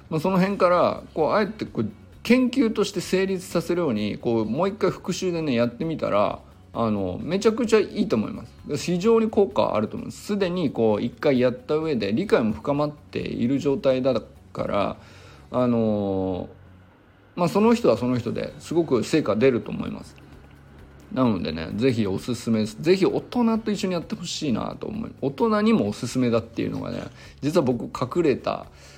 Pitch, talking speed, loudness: 140 Hz, 350 characters per minute, -24 LUFS